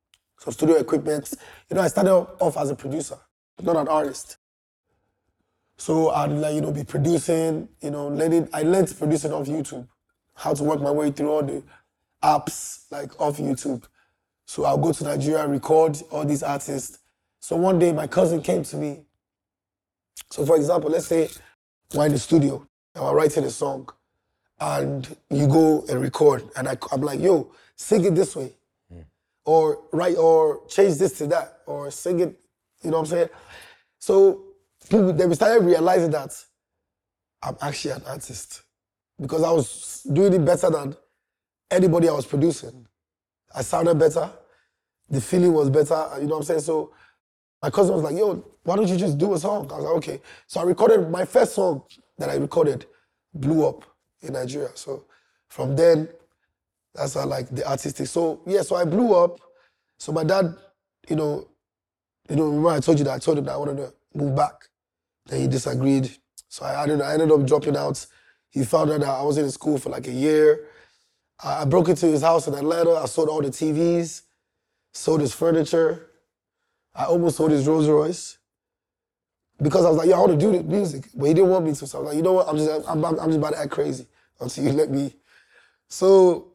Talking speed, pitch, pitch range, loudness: 195 wpm, 155 Hz, 145-175 Hz, -22 LUFS